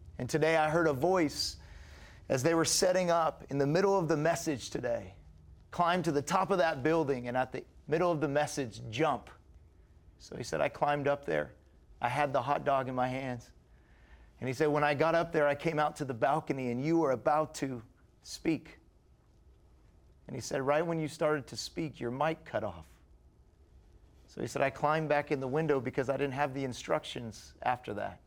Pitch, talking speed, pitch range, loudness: 140 Hz, 210 wpm, 105-155 Hz, -32 LUFS